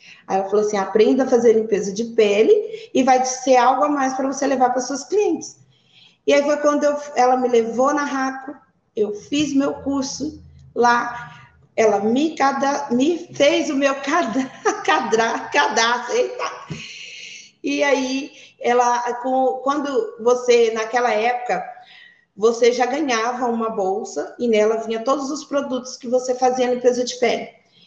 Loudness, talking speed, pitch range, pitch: -19 LUFS, 155 wpm, 230-280 Hz, 255 Hz